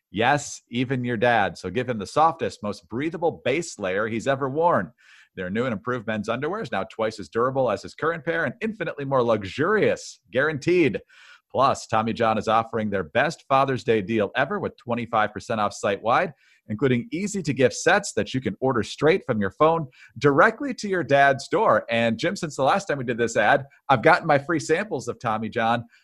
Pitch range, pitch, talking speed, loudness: 115-160 Hz, 130 Hz, 200 wpm, -23 LUFS